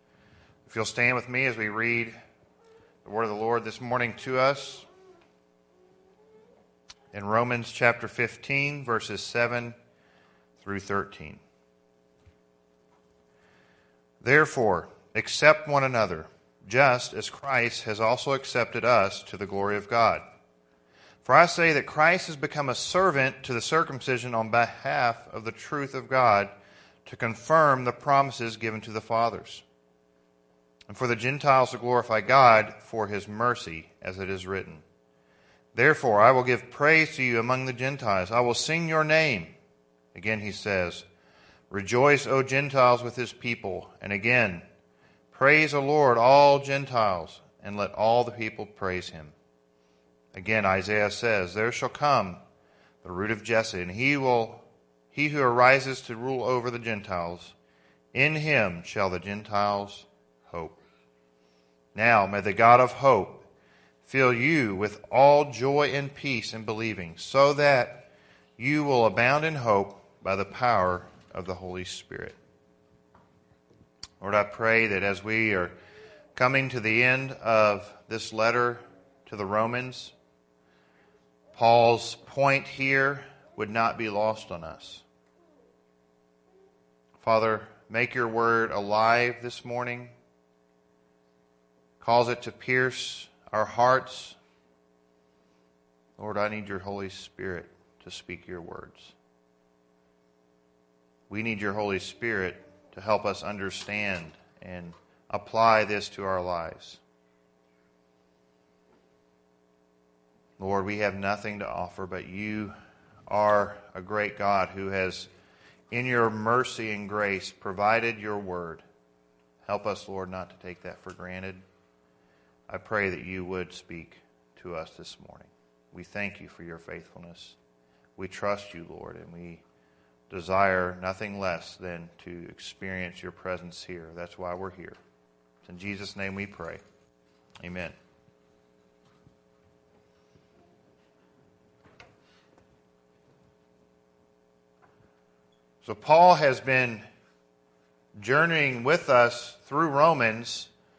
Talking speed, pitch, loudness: 130 wpm, 100 Hz, -25 LUFS